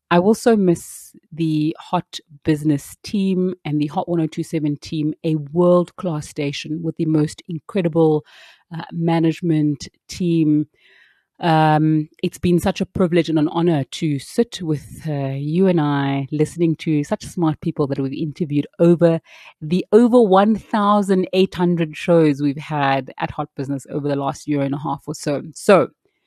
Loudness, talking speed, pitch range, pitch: -19 LUFS, 165 wpm, 150-175 Hz, 160 Hz